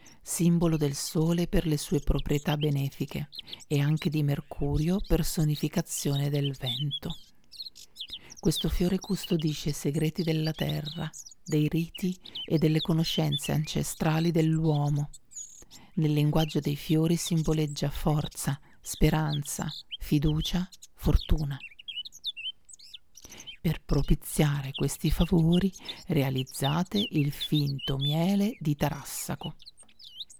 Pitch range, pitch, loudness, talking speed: 145-170 Hz, 155 Hz, -29 LUFS, 95 wpm